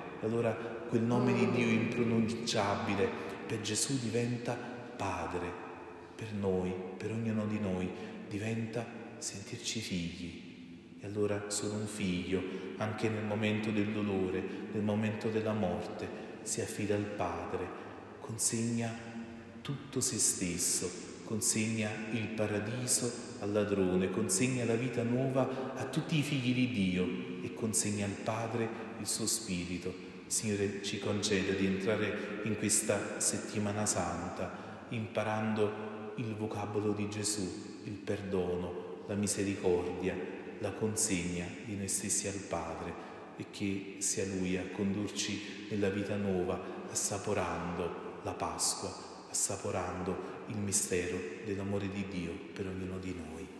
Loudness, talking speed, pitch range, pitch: -35 LUFS, 125 wpm, 95-115 Hz, 105 Hz